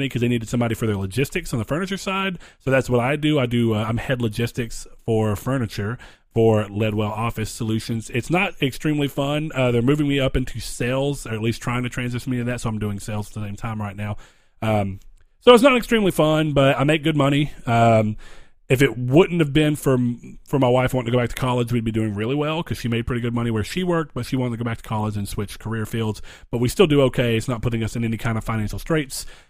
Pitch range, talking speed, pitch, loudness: 110-140 Hz, 255 wpm, 120 Hz, -21 LUFS